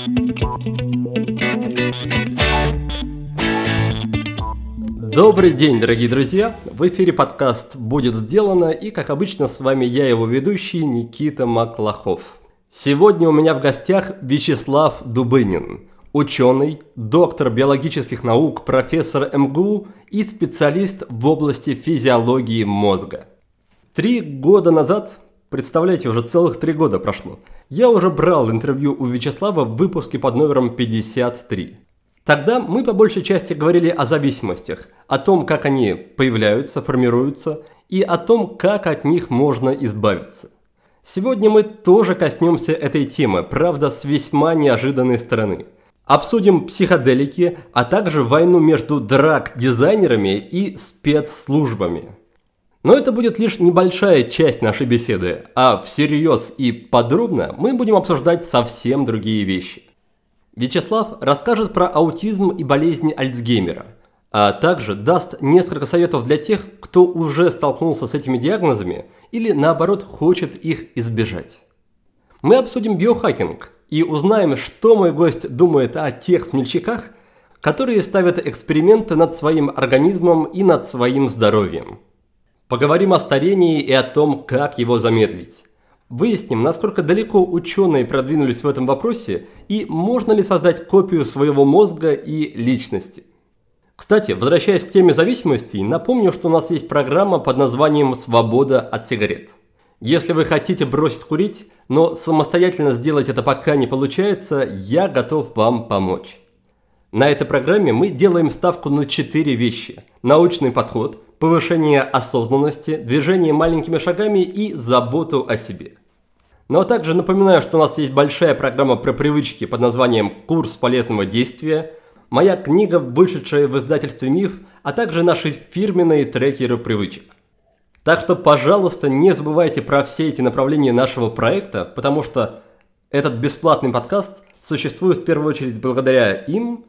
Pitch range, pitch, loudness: 125-175 Hz, 150 Hz, -17 LUFS